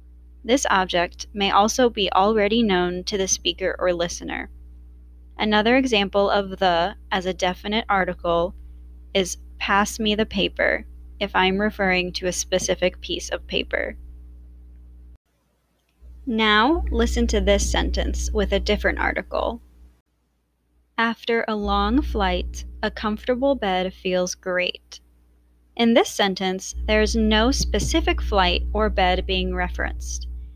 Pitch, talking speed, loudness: 185 Hz, 125 wpm, -22 LUFS